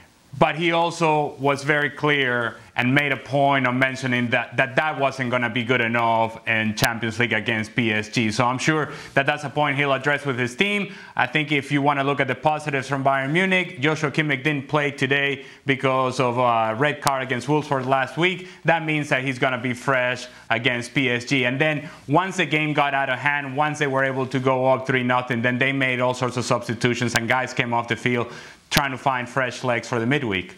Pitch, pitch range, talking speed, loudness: 135 Hz, 125-150 Hz, 225 wpm, -21 LUFS